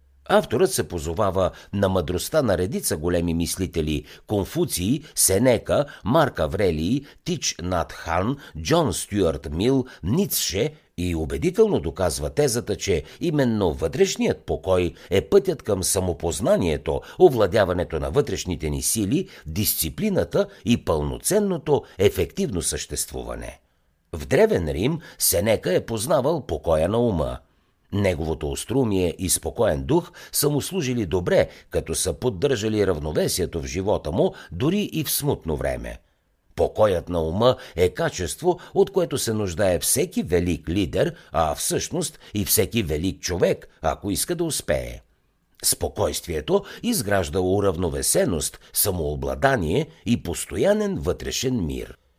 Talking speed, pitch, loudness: 115 wpm, 95 Hz, -23 LUFS